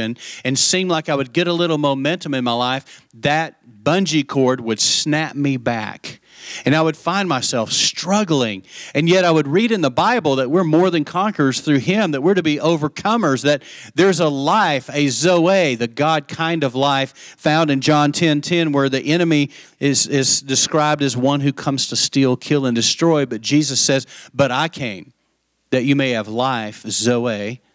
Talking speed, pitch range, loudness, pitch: 190 wpm, 130-160 Hz, -17 LUFS, 140 Hz